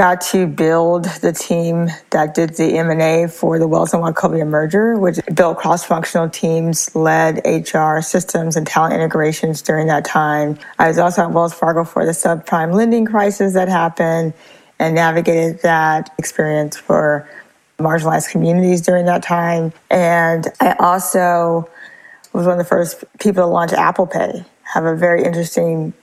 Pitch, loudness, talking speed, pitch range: 165 Hz, -15 LUFS, 160 wpm, 160-180 Hz